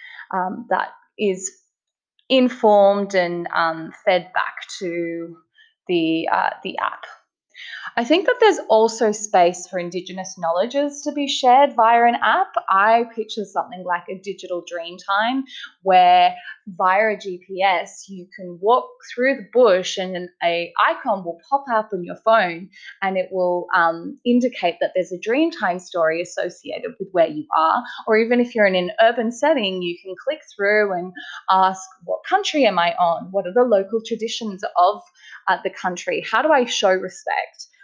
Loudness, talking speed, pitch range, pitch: -20 LUFS, 165 wpm, 180-245 Hz, 200 Hz